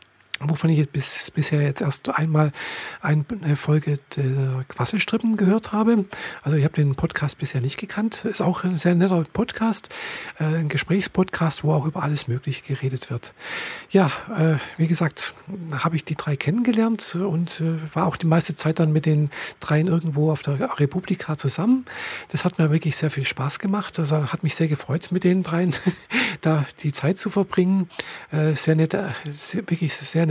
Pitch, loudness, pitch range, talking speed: 160 Hz, -23 LUFS, 150-185 Hz, 170 wpm